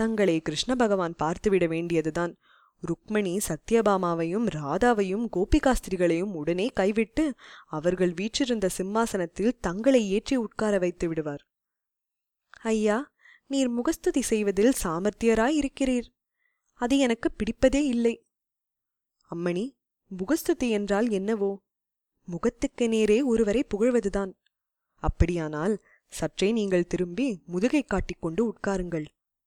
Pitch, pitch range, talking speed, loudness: 210 Hz, 180-245 Hz, 90 wpm, -26 LUFS